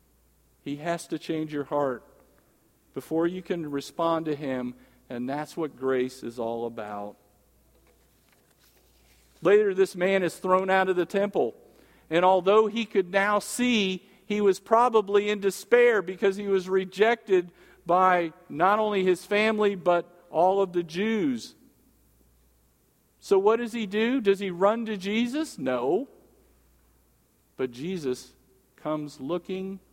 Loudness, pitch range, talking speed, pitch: -26 LUFS, 130-200 Hz, 135 wpm, 180 Hz